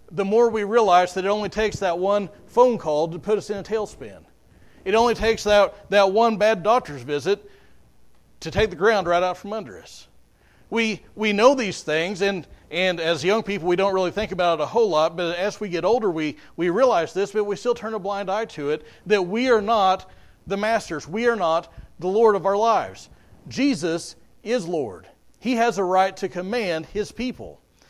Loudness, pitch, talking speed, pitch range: -22 LUFS, 200 Hz, 210 wpm, 175-220 Hz